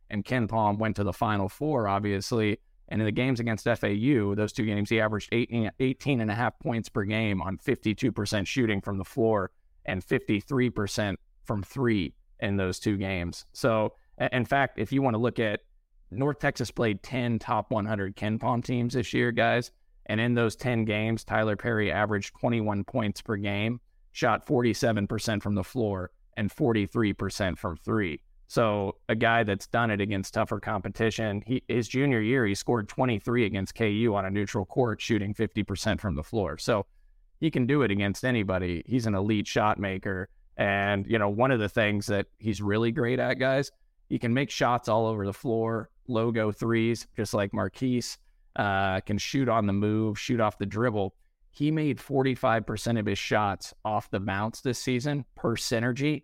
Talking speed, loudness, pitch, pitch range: 180 wpm, -28 LUFS, 110 Hz, 100-120 Hz